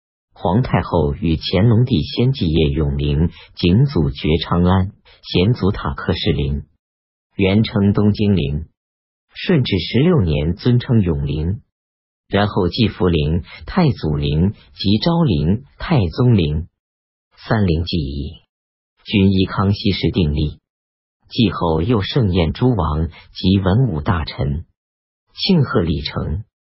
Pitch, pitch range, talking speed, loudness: 85 Hz, 75-105 Hz, 175 characters per minute, -18 LUFS